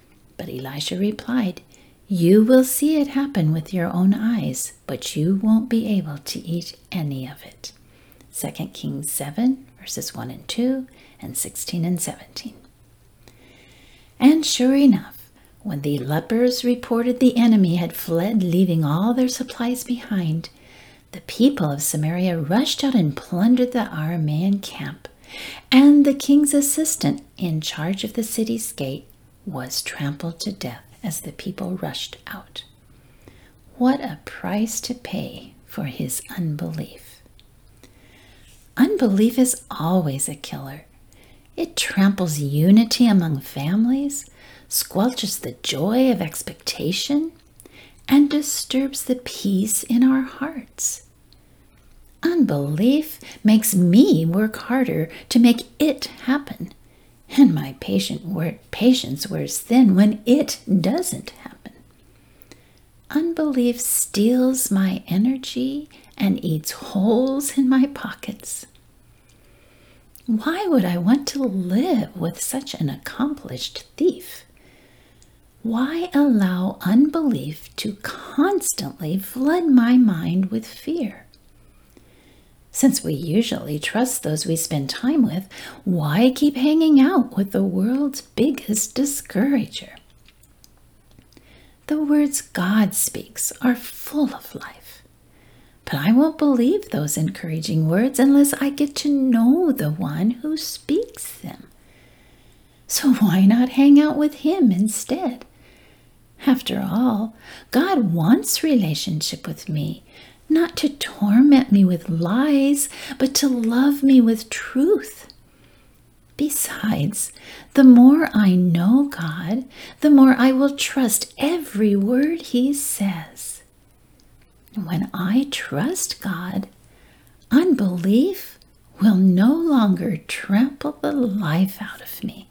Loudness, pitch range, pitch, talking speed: -20 LUFS, 180-270 Hz, 230 Hz, 115 wpm